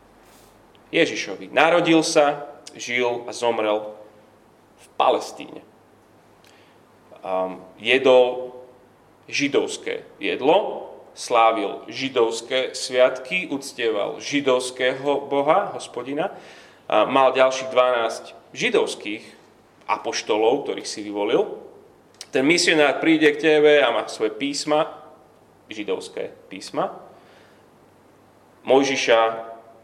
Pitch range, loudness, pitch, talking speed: 120-160 Hz, -21 LUFS, 135 Hz, 75 wpm